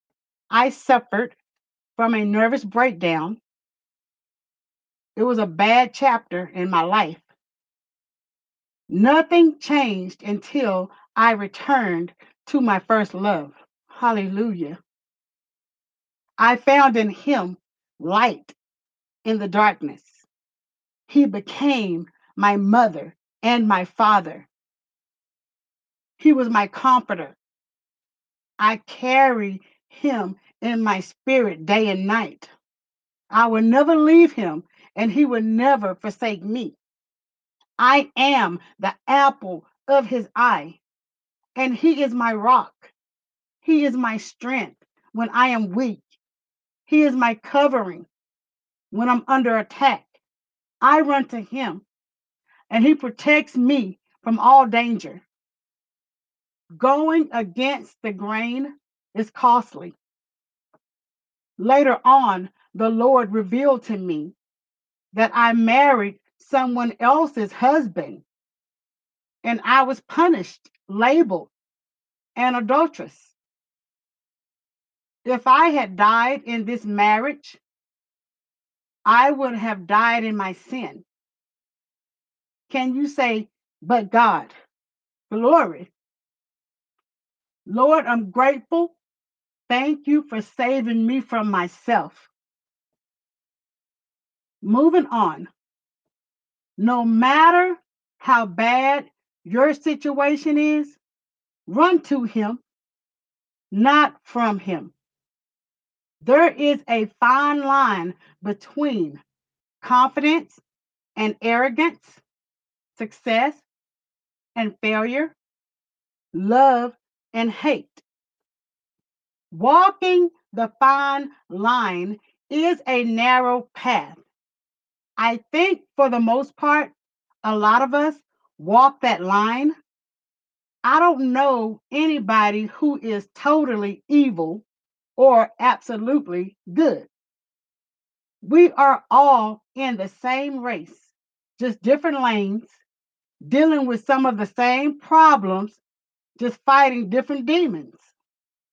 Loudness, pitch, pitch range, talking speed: -19 LUFS, 245 Hz, 215-275 Hz, 95 wpm